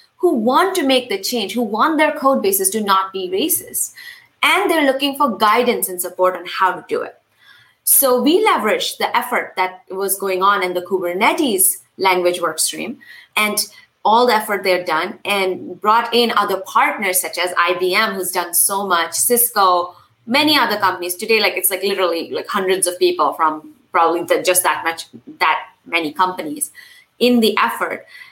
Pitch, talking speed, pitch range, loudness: 195 Hz, 180 wpm, 180-260 Hz, -16 LUFS